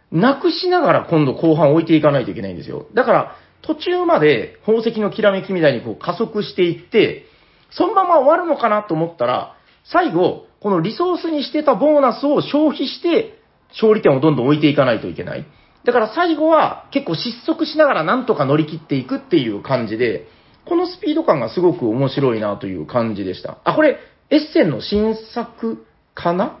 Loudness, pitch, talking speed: -17 LUFS, 240 Hz, 395 characters per minute